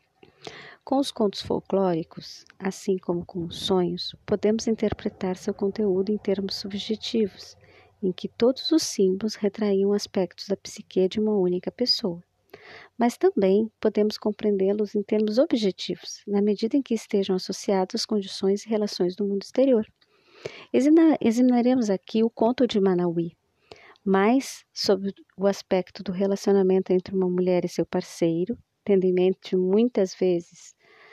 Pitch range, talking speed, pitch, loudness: 185-220 Hz, 140 wpm, 200 Hz, -25 LUFS